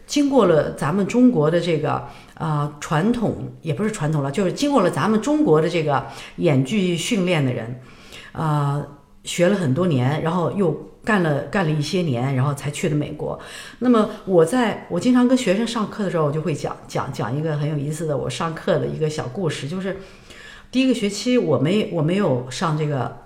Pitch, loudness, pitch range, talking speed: 165 Hz, -21 LUFS, 145-200 Hz, 290 characters per minute